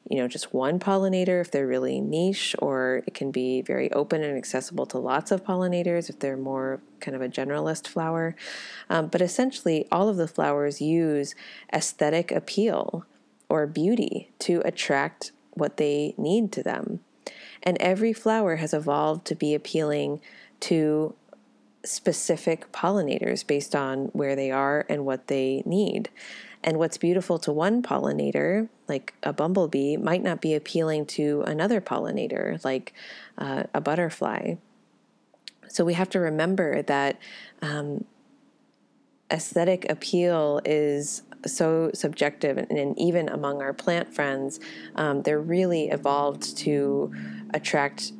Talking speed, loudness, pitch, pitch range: 140 wpm, -26 LUFS, 155 Hz, 140-180 Hz